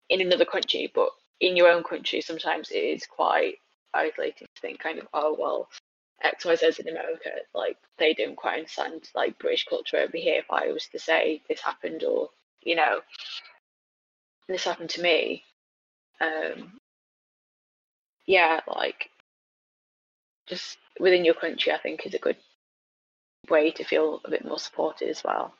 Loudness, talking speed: -26 LUFS, 155 wpm